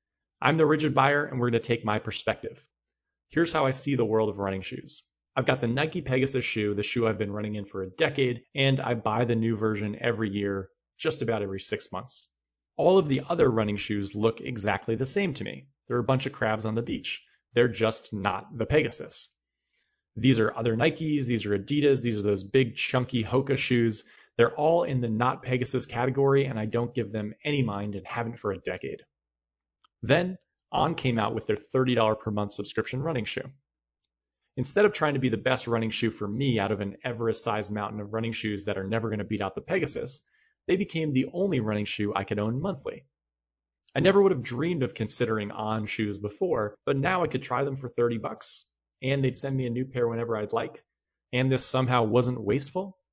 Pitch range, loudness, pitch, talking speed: 105-135 Hz, -27 LUFS, 115 Hz, 215 wpm